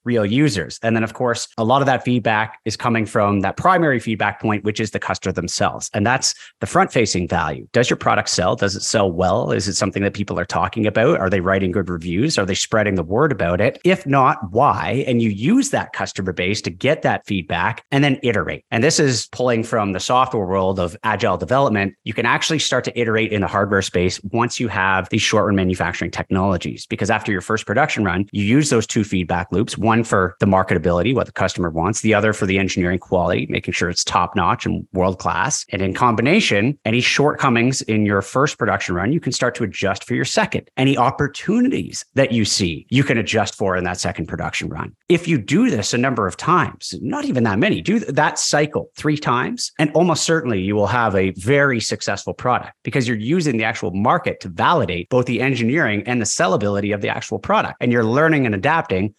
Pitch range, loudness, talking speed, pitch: 95-125 Hz, -18 LUFS, 220 wpm, 110 Hz